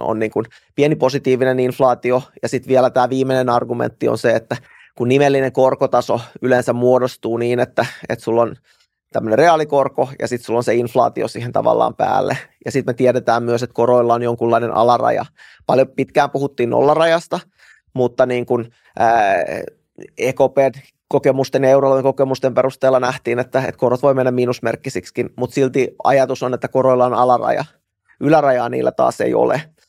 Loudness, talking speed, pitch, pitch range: -17 LUFS, 155 wpm, 130 Hz, 120-135 Hz